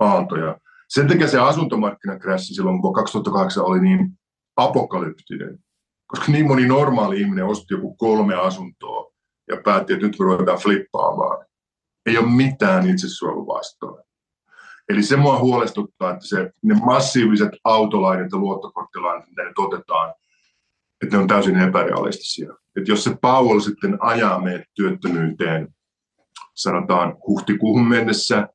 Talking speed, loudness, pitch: 130 wpm, -19 LUFS, 125 Hz